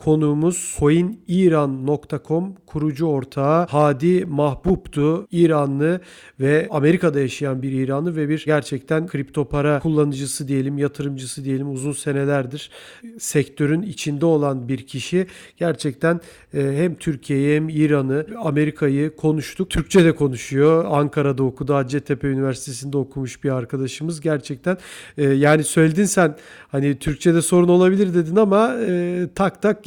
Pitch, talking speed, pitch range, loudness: 150 Hz, 115 wpm, 140-170 Hz, -20 LUFS